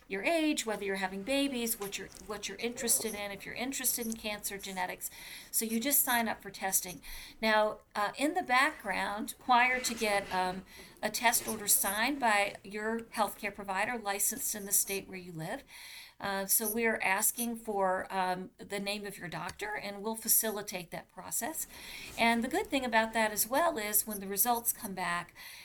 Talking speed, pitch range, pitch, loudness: 185 wpm, 195-235 Hz, 210 Hz, -31 LUFS